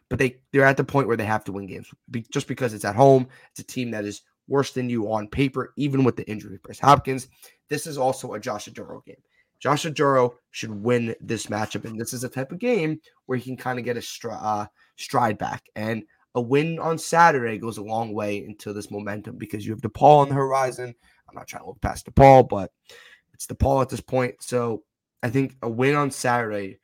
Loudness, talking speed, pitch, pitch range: -23 LUFS, 235 wpm, 125 Hz, 110-135 Hz